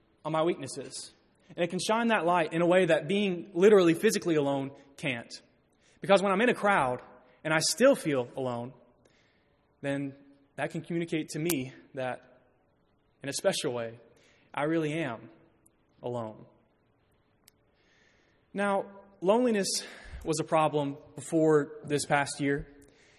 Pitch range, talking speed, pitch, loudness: 135-175 Hz, 135 wpm, 150 Hz, -29 LUFS